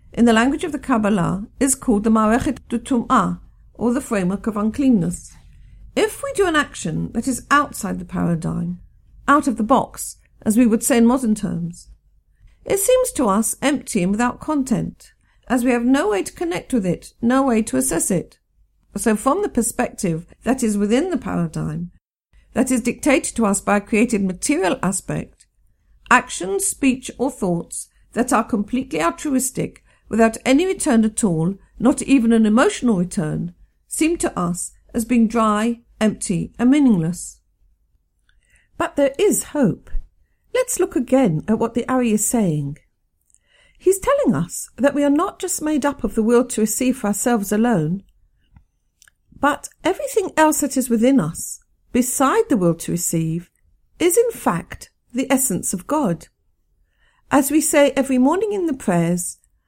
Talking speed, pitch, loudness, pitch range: 165 wpm, 240 Hz, -19 LUFS, 205-280 Hz